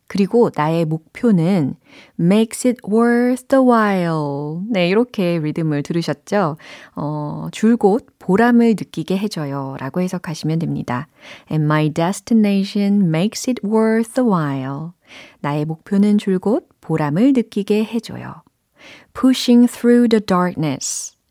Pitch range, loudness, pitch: 160-230 Hz, -18 LUFS, 195 Hz